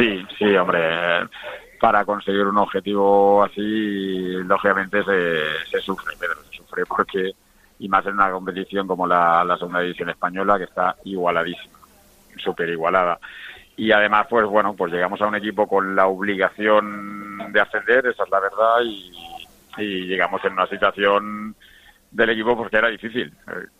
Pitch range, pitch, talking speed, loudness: 95-105 Hz, 100 Hz, 155 wpm, -20 LUFS